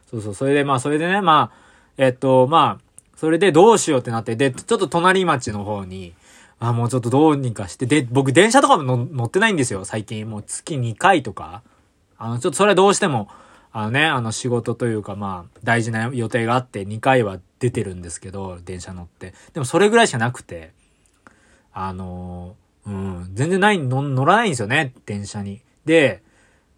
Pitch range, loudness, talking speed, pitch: 100-140 Hz, -19 LUFS, 365 characters per minute, 120 Hz